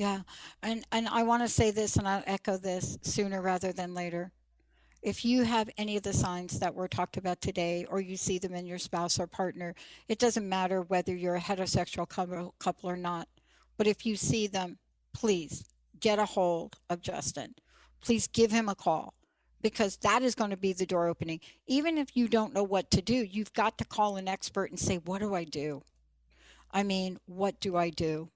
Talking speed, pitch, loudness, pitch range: 205 wpm, 190 Hz, -32 LUFS, 180-210 Hz